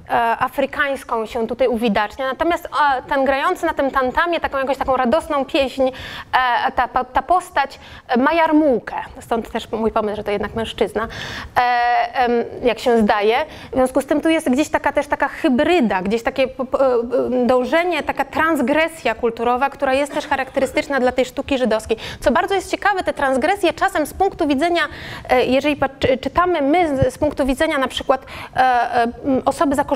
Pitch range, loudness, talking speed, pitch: 250-300 Hz, -18 LUFS, 150 wpm, 275 Hz